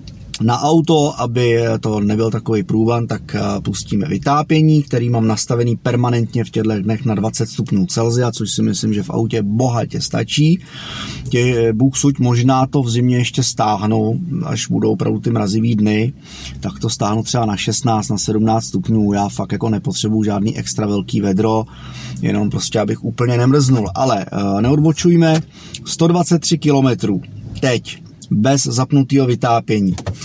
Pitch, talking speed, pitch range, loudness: 115 Hz, 145 wpm, 110-135 Hz, -16 LUFS